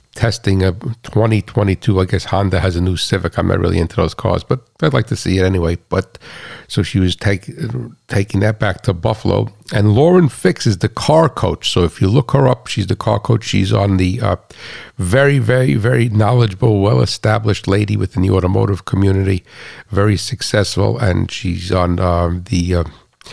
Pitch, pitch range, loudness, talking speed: 100 Hz, 95-115 Hz, -16 LUFS, 190 wpm